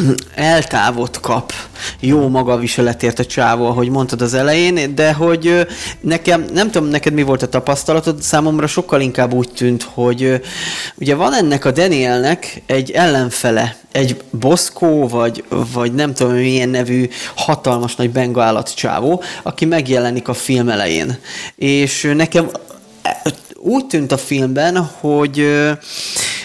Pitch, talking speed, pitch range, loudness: 135 Hz, 130 wpm, 125-160 Hz, -15 LUFS